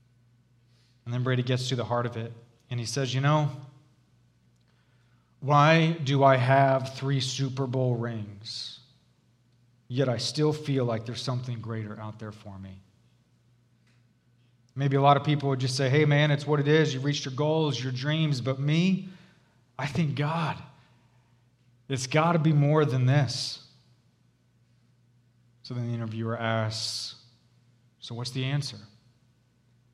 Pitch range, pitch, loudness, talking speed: 120-140 Hz, 125 Hz, -27 LUFS, 150 wpm